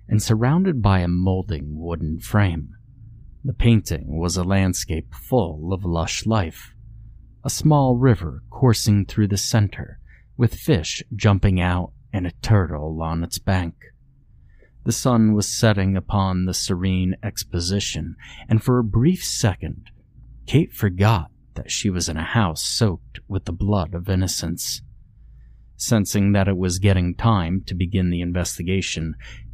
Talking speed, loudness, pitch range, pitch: 140 wpm, -21 LUFS, 90-115 Hz, 100 Hz